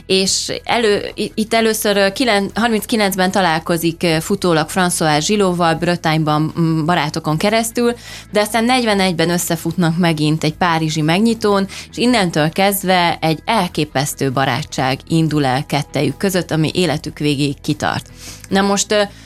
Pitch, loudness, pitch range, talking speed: 175 Hz, -16 LUFS, 155-200 Hz, 110 wpm